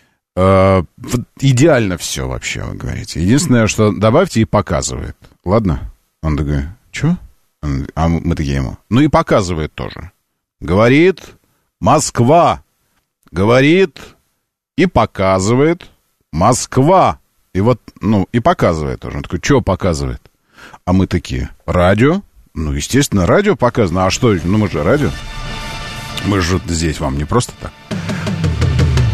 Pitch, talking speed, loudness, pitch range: 95 Hz, 125 wpm, -15 LUFS, 80-120 Hz